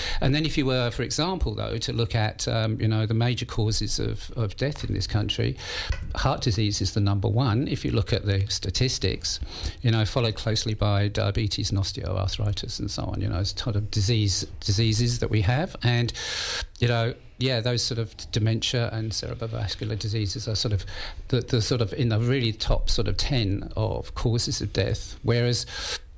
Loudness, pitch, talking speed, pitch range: -26 LUFS, 110 Hz, 195 wpm, 100-120 Hz